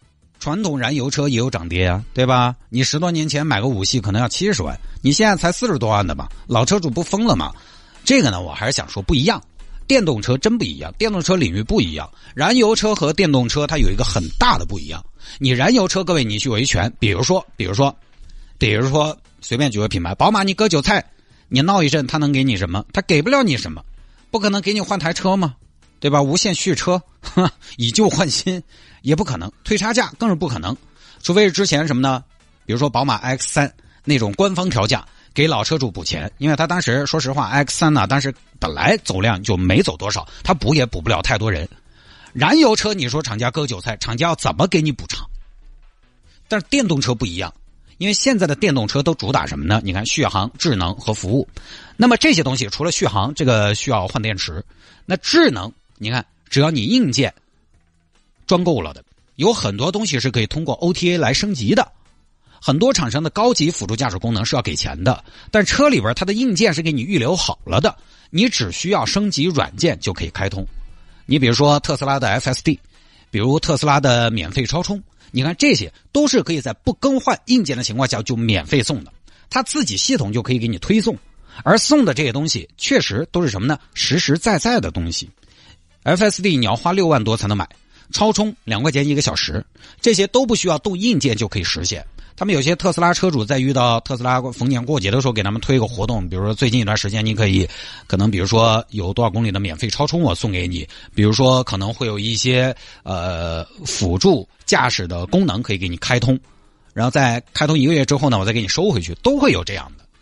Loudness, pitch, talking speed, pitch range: -18 LUFS, 130 Hz, 320 characters per minute, 105-170 Hz